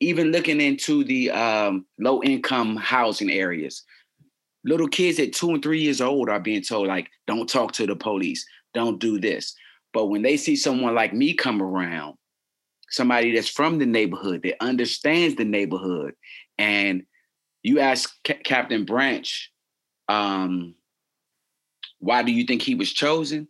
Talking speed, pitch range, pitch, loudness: 155 wpm, 105-160 Hz, 125 Hz, -23 LUFS